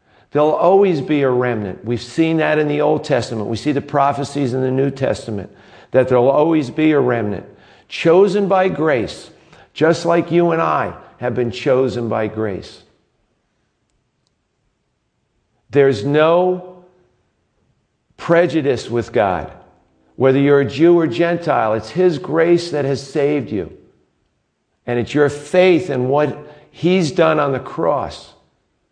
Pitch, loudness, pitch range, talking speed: 145 Hz, -16 LUFS, 120-165 Hz, 140 wpm